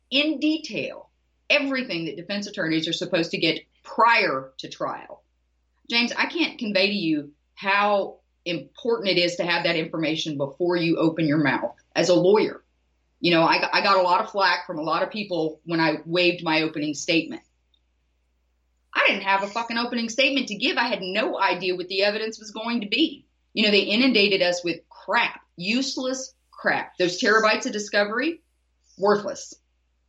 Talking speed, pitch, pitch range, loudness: 175 wpm, 185 Hz, 160-230 Hz, -23 LUFS